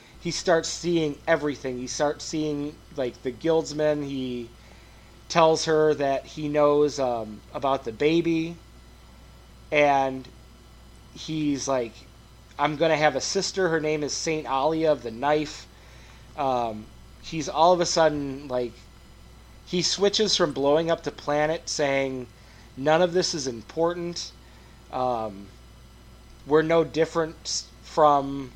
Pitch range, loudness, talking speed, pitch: 120-160 Hz, -25 LUFS, 130 wpm, 145 Hz